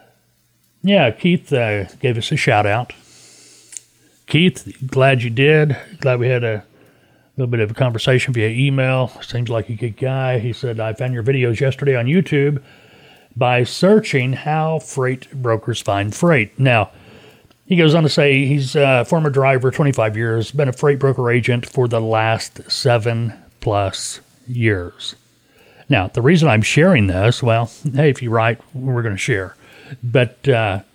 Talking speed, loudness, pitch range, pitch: 165 wpm, -17 LUFS, 115-140 Hz, 130 Hz